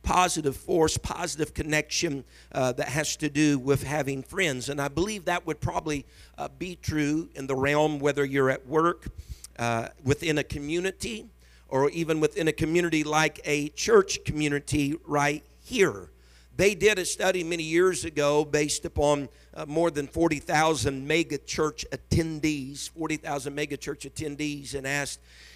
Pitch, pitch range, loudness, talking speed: 150 Hz, 140-160 Hz, -27 LUFS, 155 wpm